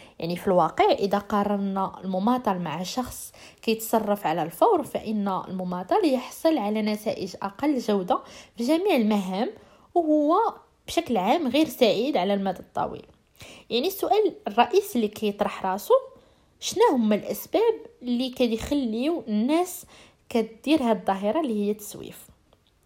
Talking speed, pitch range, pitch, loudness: 125 wpm, 205-305 Hz, 230 Hz, -25 LUFS